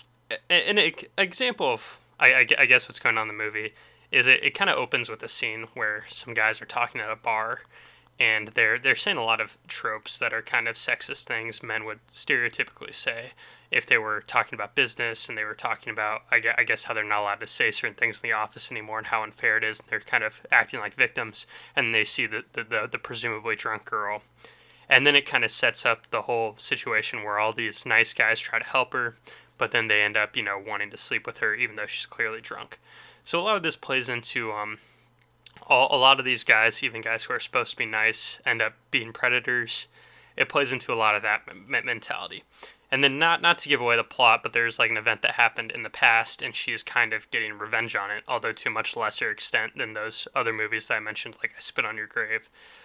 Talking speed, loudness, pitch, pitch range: 240 wpm, -24 LUFS, 115 Hz, 110-140 Hz